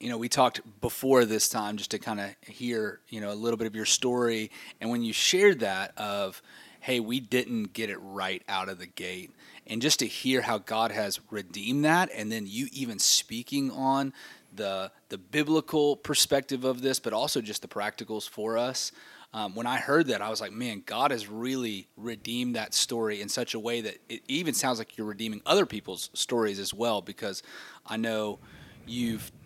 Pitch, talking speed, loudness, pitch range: 115 Hz, 200 wpm, -29 LUFS, 110-130 Hz